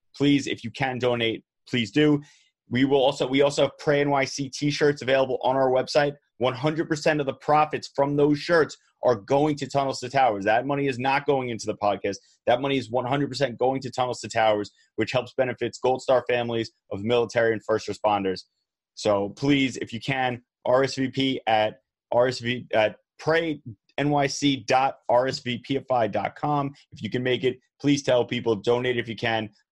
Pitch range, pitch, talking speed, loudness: 120-140 Hz, 130 Hz, 170 wpm, -24 LUFS